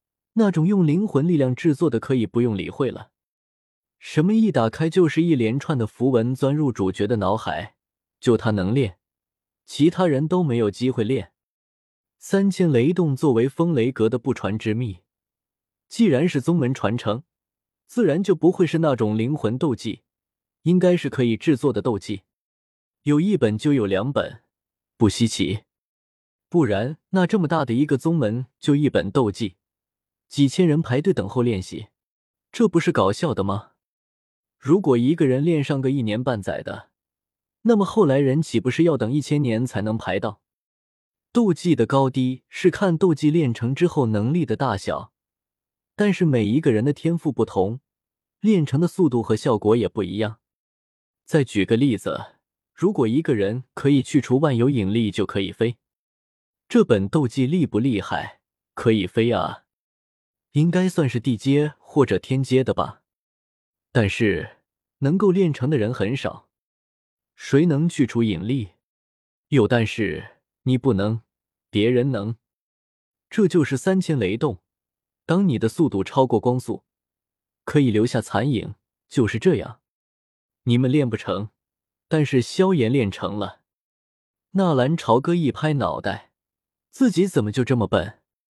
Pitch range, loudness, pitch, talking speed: 110-155 Hz, -21 LUFS, 130 Hz, 225 characters per minute